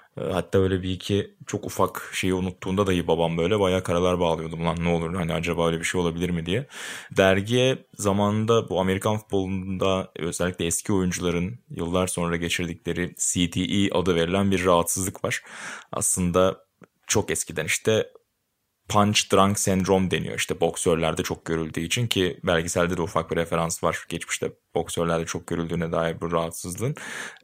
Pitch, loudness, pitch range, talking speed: 90 Hz, -24 LUFS, 85-100 Hz, 150 wpm